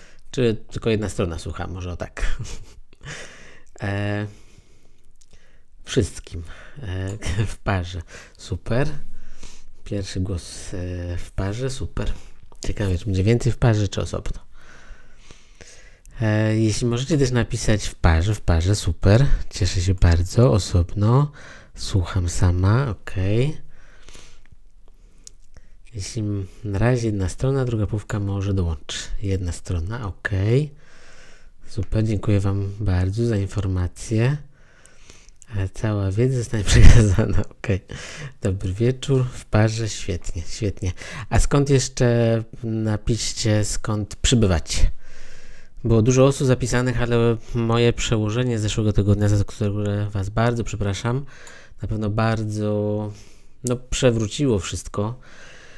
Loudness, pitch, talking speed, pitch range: -22 LUFS, 105 Hz, 110 wpm, 95-115 Hz